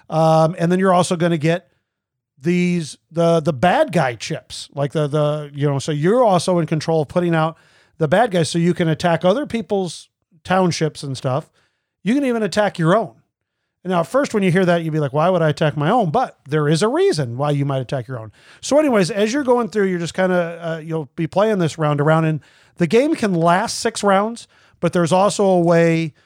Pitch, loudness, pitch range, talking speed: 170 Hz, -18 LUFS, 155-185 Hz, 235 wpm